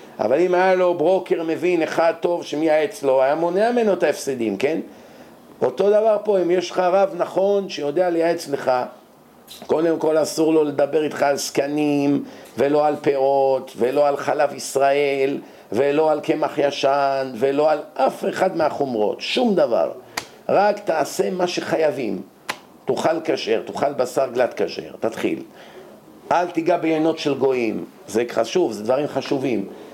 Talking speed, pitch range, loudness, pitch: 150 wpm, 140-180 Hz, -20 LUFS, 155 Hz